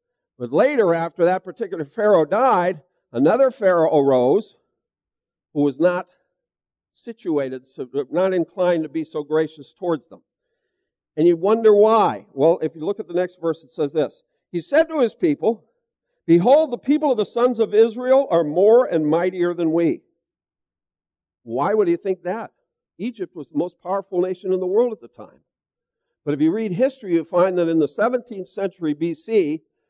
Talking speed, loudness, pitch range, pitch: 175 wpm, -20 LUFS, 170-250 Hz, 190 Hz